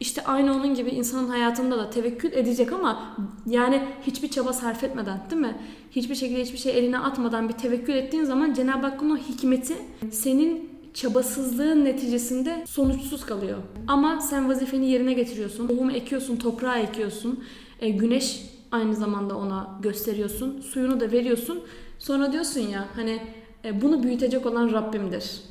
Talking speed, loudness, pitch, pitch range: 145 wpm, -26 LUFS, 250 Hz, 230-270 Hz